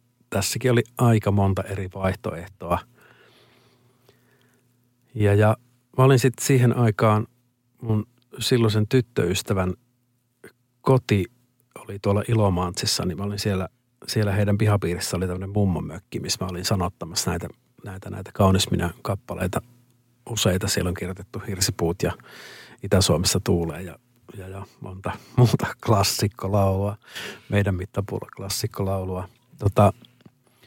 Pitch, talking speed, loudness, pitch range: 105 Hz, 115 wpm, -23 LUFS, 95-120 Hz